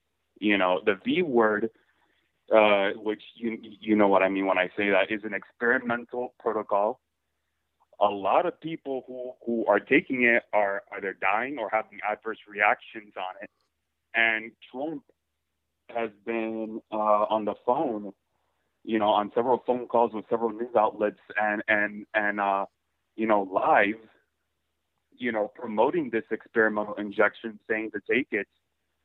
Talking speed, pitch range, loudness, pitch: 155 wpm, 95-115 Hz, -26 LUFS, 105 Hz